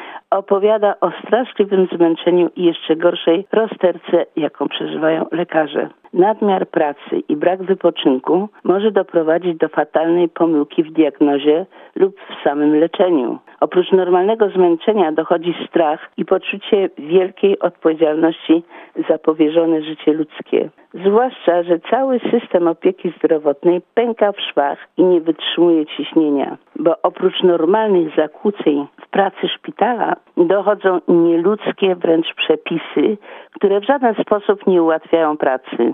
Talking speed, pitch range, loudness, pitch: 120 wpm, 160-200 Hz, -16 LUFS, 175 Hz